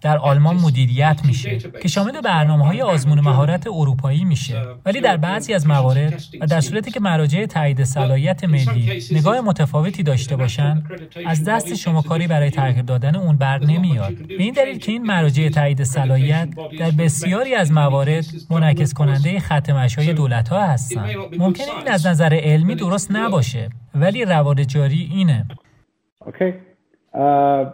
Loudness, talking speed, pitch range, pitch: -18 LUFS, 150 wpm, 140-180 Hz, 155 Hz